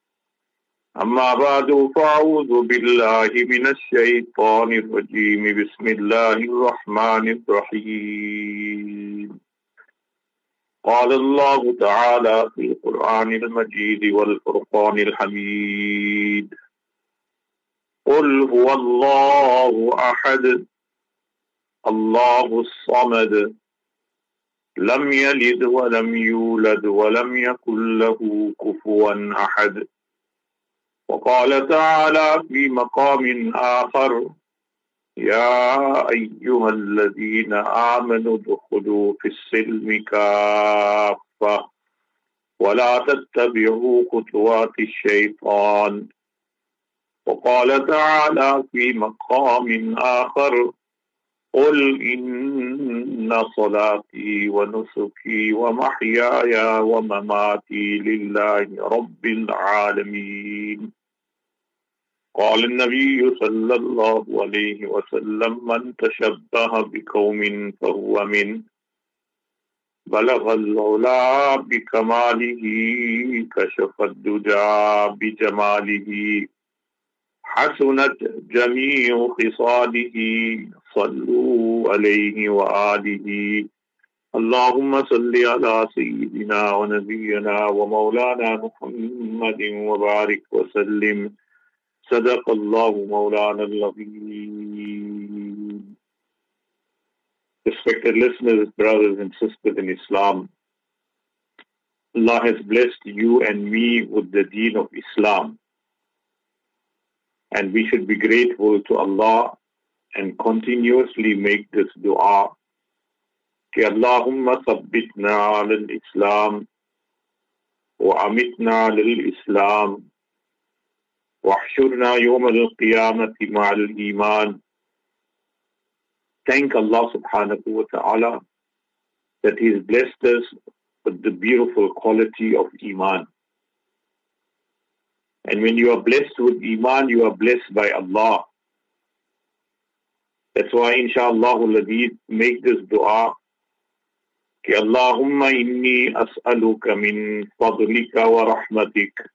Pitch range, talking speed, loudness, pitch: 105-155 Hz, 75 wpm, -19 LUFS, 120 Hz